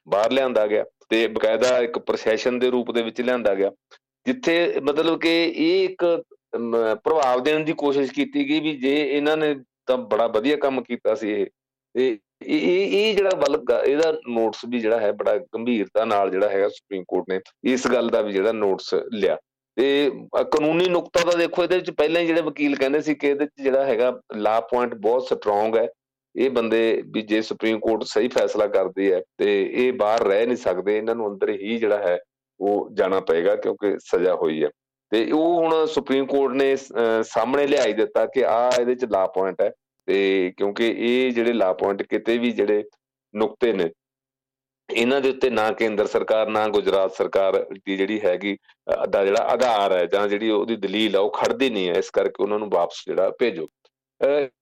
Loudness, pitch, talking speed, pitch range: -22 LUFS, 135 Hz, 185 wpm, 115-170 Hz